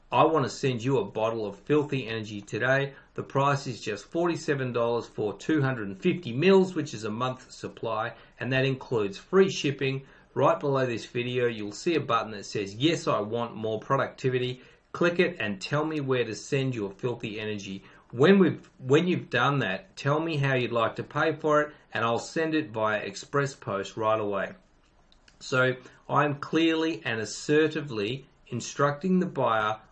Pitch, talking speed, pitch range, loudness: 130 Hz, 185 wpm, 110-150 Hz, -27 LUFS